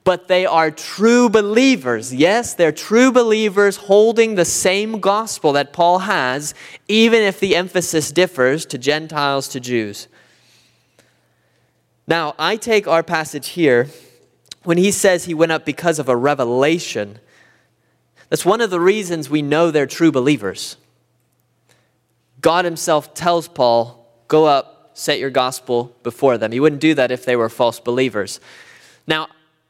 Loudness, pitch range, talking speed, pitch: -16 LUFS, 125-185 Hz, 145 wpm, 155 Hz